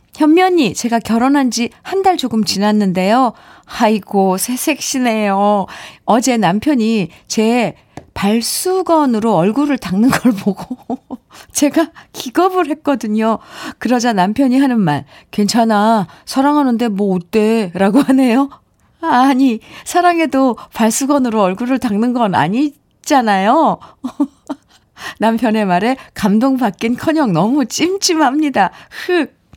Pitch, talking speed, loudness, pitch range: 245 Hz, 245 characters per minute, -14 LUFS, 215-285 Hz